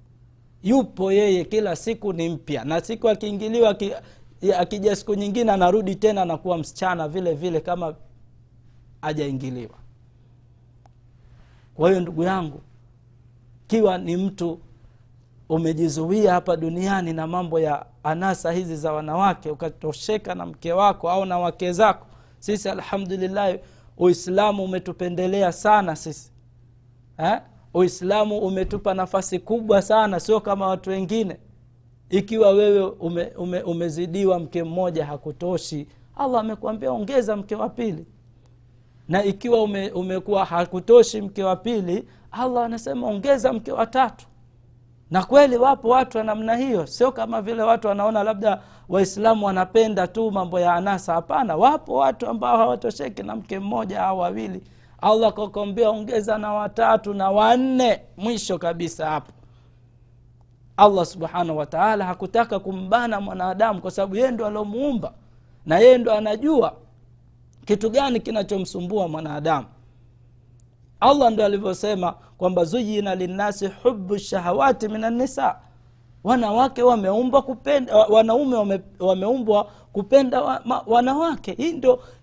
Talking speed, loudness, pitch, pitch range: 120 wpm, -21 LUFS, 190 Hz, 155-215 Hz